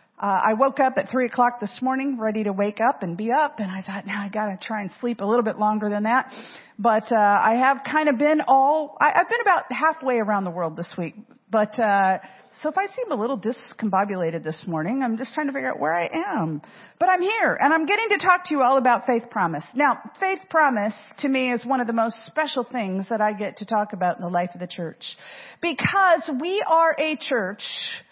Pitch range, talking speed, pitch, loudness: 205-285 Hz, 235 wpm, 235 Hz, -22 LUFS